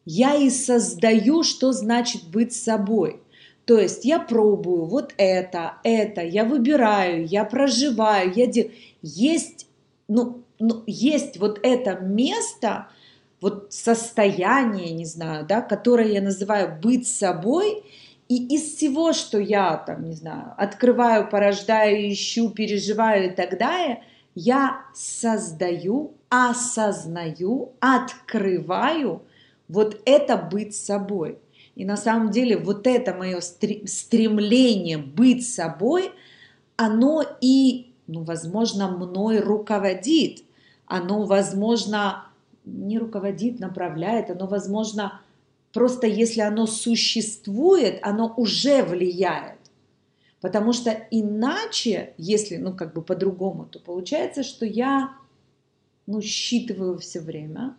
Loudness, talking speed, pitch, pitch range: -22 LUFS, 110 wpm, 215 Hz, 195-245 Hz